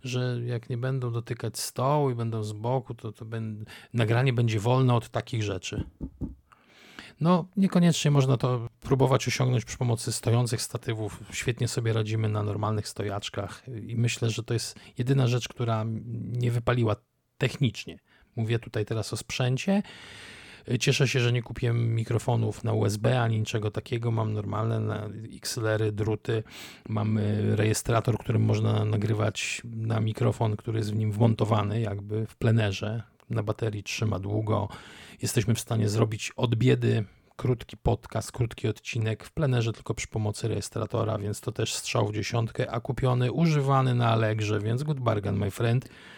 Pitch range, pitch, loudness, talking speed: 110-125 Hz, 115 Hz, -28 LUFS, 150 wpm